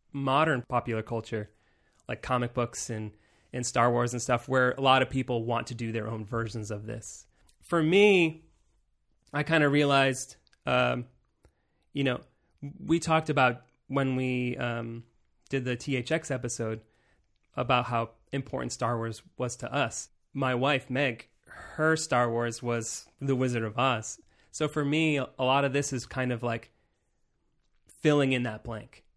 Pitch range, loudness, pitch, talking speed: 115-140 Hz, -29 LUFS, 125 Hz, 160 wpm